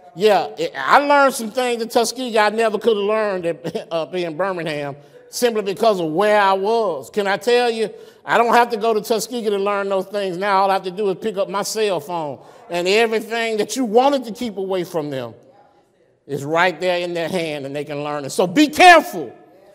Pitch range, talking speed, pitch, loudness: 180-230 Hz, 220 wpm, 210 Hz, -18 LUFS